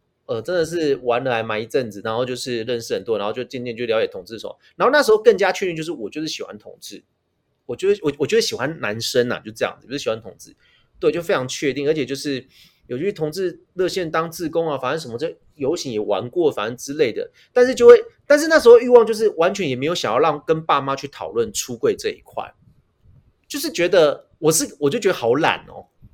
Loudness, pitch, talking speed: -19 LUFS, 180 Hz, 350 characters per minute